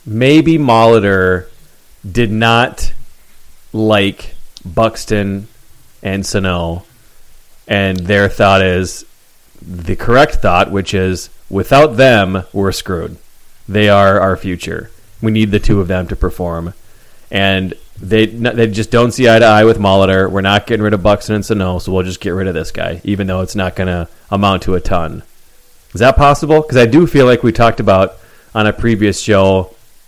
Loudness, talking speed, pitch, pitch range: -12 LUFS, 170 wpm, 100 Hz, 95-115 Hz